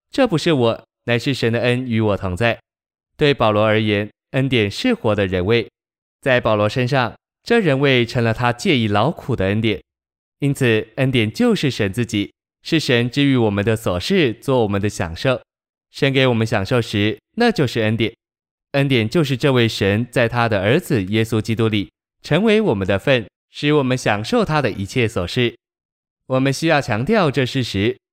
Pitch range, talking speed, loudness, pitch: 105-140 Hz, 260 characters per minute, -18 LUFS, 120 Hz